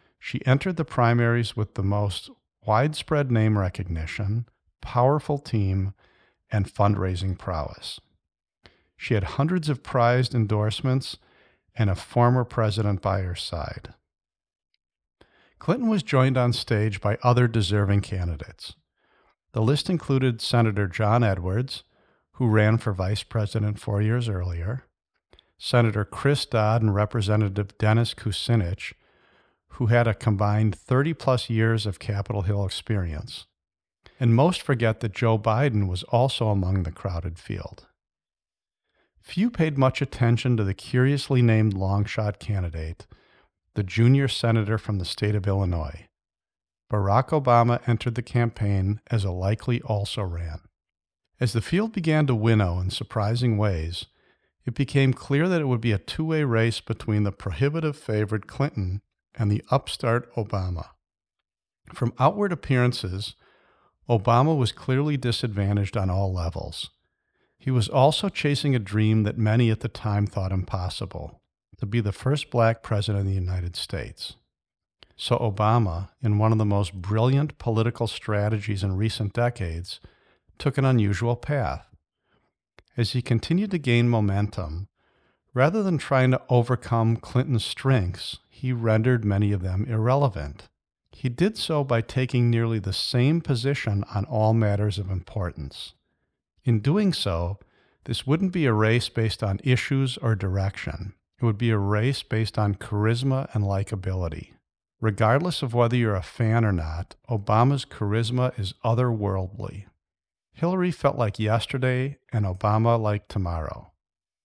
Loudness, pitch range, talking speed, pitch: -24 LUFS, 100-125 Hz, 140 wpm, 110 Hz